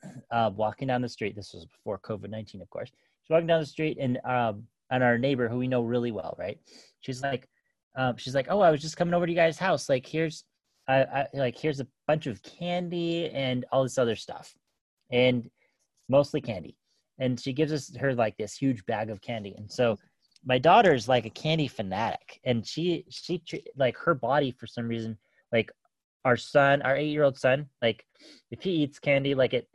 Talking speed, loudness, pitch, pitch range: 210 wpm, -28 LUFS, 130 Hz, 115-150 Hz